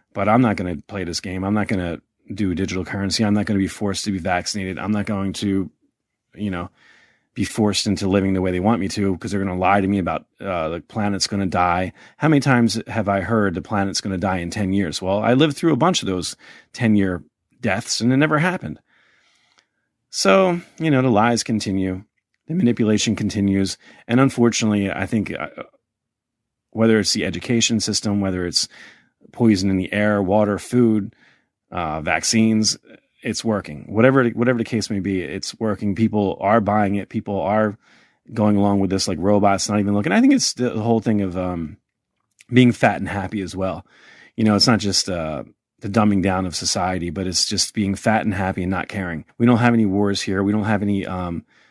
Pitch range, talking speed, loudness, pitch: 95-110 Hz, 210 wpm, -20 LUFS, 100 Hz